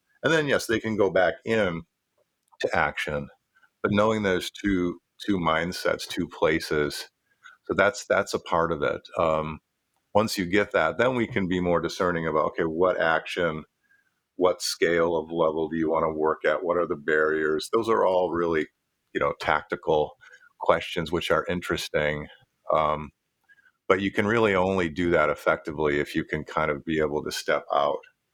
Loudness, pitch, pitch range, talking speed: -25 LUFS, 90 Hz, 80-110 Hz, 180 wpm